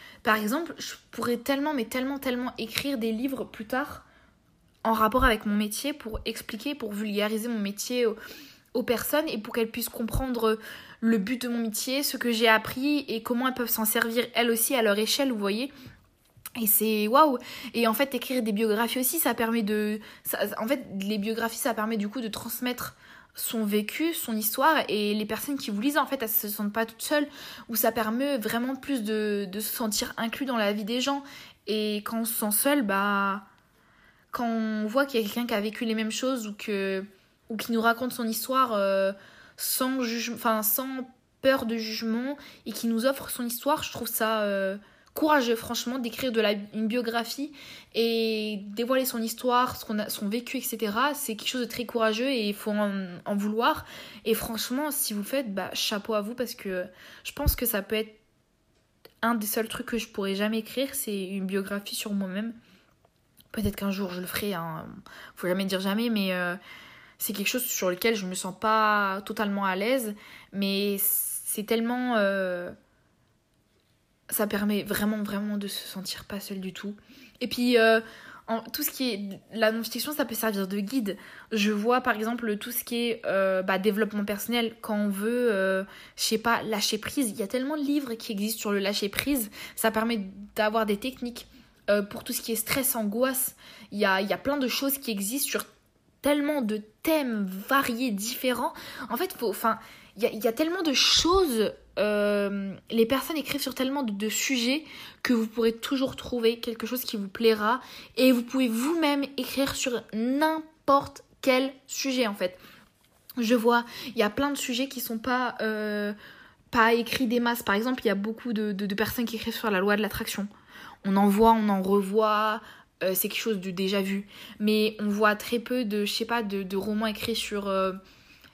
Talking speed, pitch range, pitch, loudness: 205 wpm, 210-250 Hz, 225 Hz, -27 LUFS